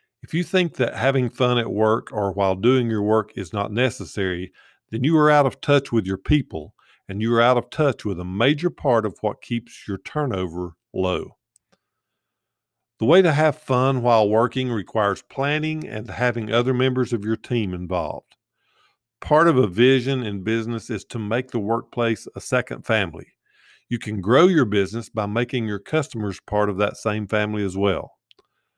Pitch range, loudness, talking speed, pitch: 105-130 Hz, -22 LUFS, 185 wpm, 115 Hz